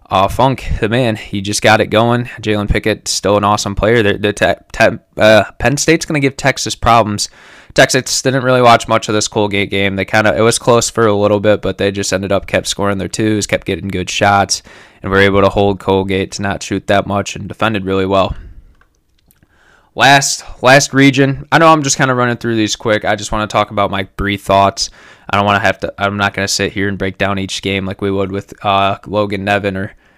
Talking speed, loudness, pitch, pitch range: 240 wpm, -13 LUFS, 100 Hz, 100-115 Hz